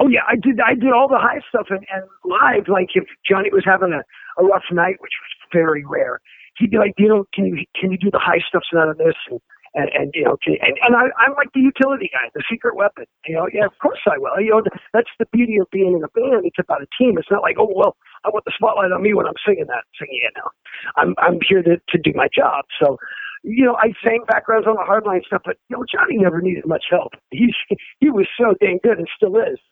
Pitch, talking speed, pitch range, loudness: 215 Hz, 270 wpm, 190-260 Hz, -17 LUFS